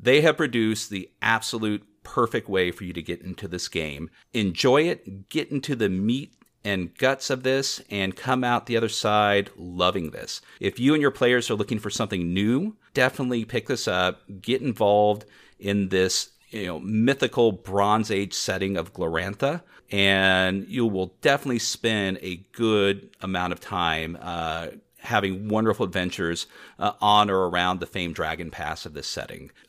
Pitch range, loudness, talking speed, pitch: 95-120 Hz, -24 LUFS, 170 wpm, 100 Hz